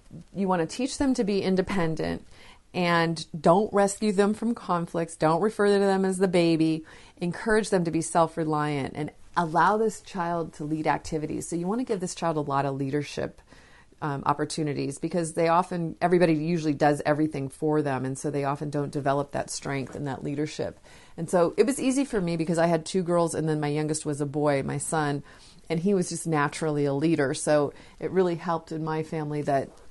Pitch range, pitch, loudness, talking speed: 150-180 Hz, 165 Hz, -26 LUFS, 205 wpm